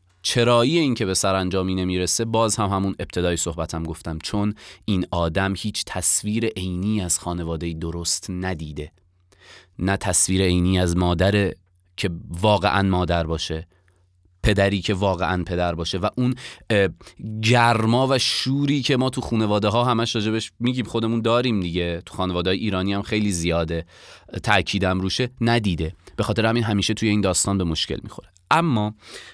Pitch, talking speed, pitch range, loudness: 95 Hz, 150 wpm, 90-110 Hz, -22 LUFS